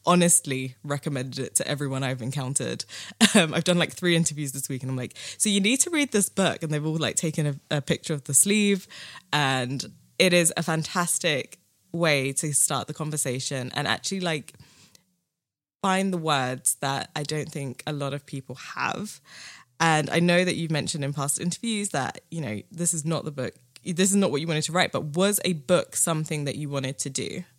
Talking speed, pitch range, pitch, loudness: 210 wpm, 140-175 Hz, 155 Hz, -25 LUFS